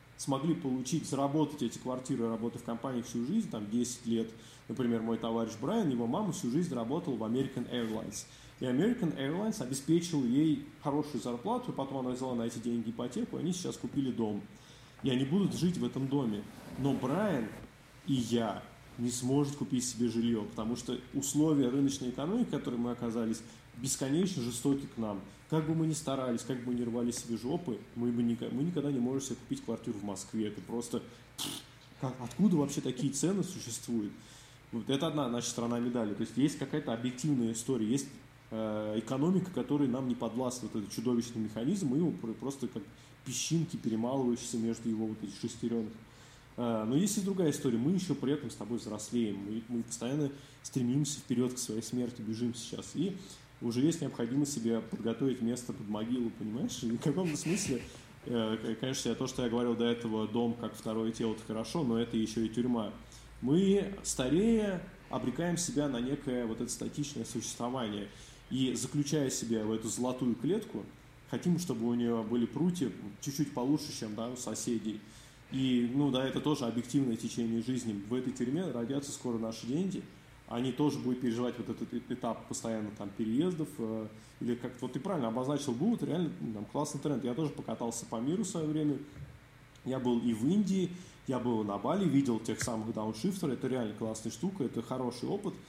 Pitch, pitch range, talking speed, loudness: 125 Hz, 115-140 Hz, 175 wpm, -34 LUFS